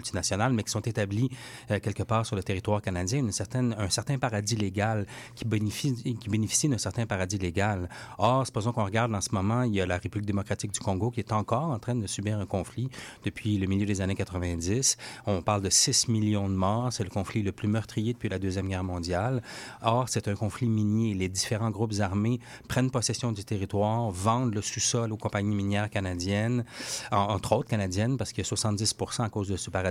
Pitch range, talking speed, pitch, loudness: 100-120 Hz, 215 wpm, 110 Hz, -29 LUFS